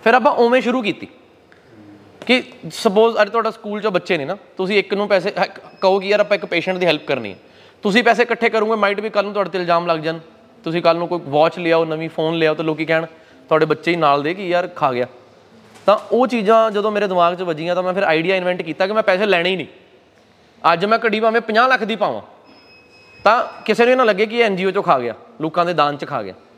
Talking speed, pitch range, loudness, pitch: 245 wpm, 165-220 Hz, -17 LUFS, 190 Hz